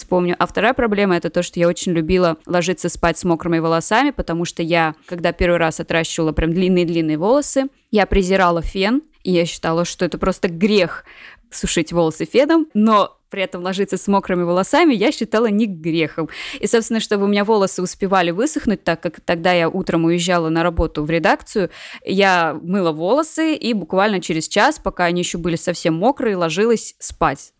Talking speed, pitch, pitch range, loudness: 180 wpm, 180 Hz, 170-210 Hz, -18 LUFS